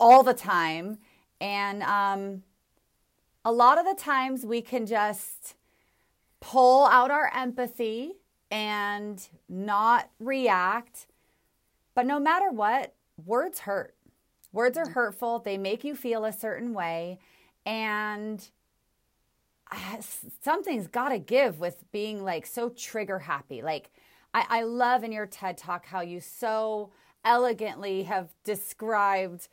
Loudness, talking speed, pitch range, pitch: -27 LUFS, 125 wpm, 200-245 Hz, 220 Hz